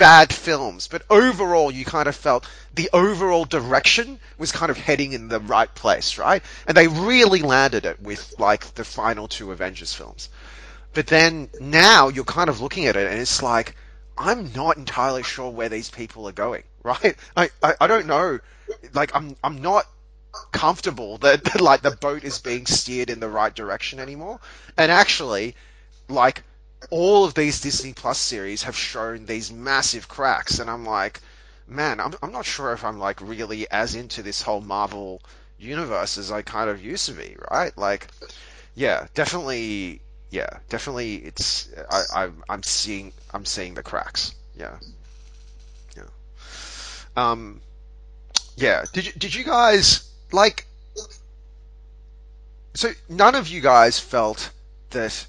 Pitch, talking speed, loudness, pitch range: 125 Hz, 160 wpm, -20 LUFS, 100-160 Hz